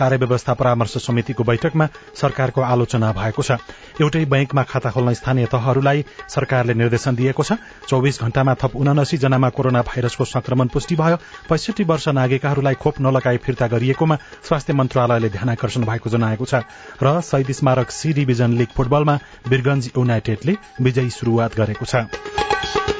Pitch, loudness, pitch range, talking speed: 130 Hz, -19 LUFS, 120-145 Hz, 145 wpm